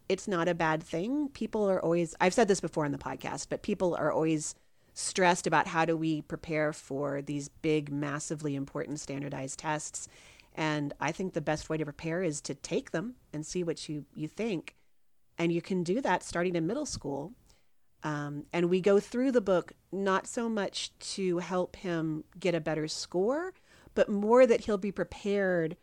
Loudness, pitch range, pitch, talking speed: -31 LUFS, 155-190 Hz, 170 Hz, 185 wpm